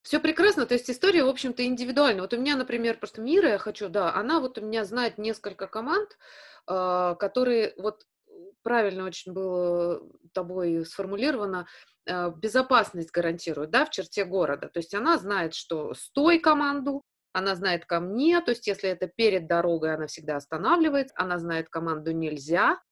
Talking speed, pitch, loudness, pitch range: 160 wpm, 205 Hz, -26 LUFS, 175-255 Hz